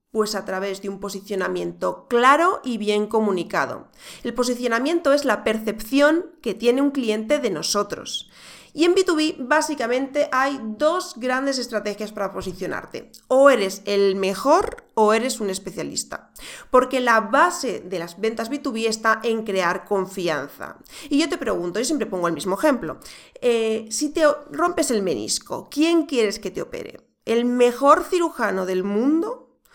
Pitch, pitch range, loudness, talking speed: 235 Hz, 205-295 Hz, -21 LUFS, 155 wpm